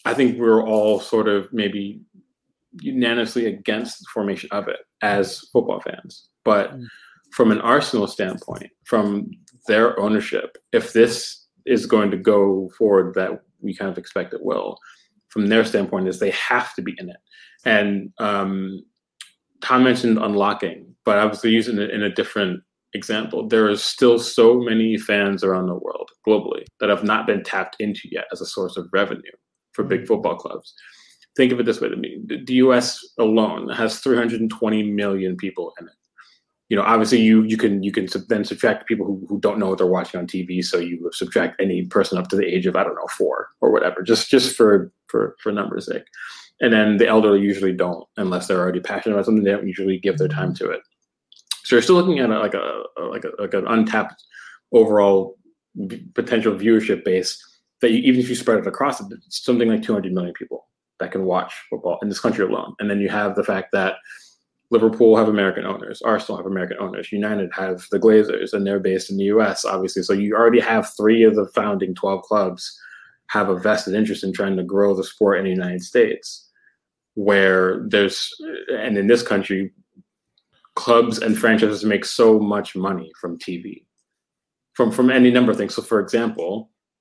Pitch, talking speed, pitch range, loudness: 110 Hz, 195 wpm, 100-120 Hz, -19 LUFS